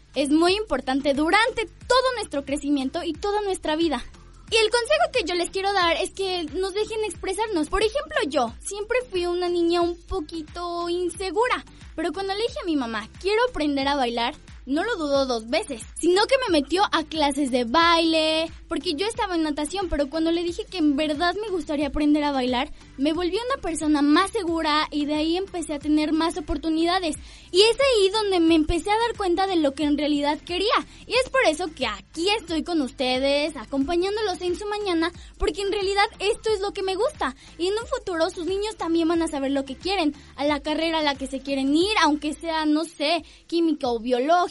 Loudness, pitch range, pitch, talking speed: -24 LUFS, 300-390 Hz, 335 Hz, 210 wpm